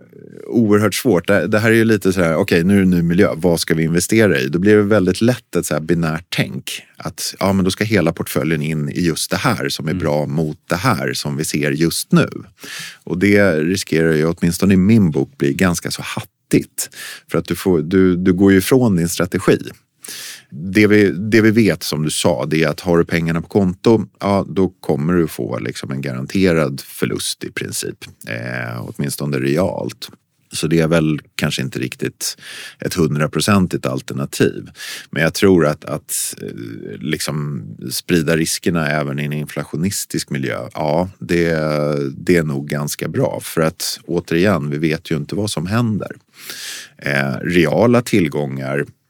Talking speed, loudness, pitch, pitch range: 185 wpm, -17 LUFS, 85 Hz, 75-95 Hz